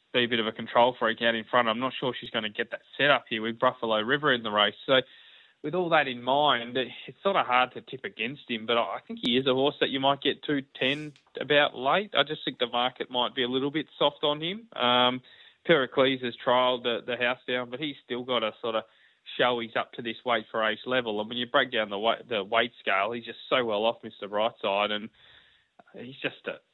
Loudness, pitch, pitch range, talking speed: -27 LUFS, 125 Hz, 115-135 Hz, 255 wpm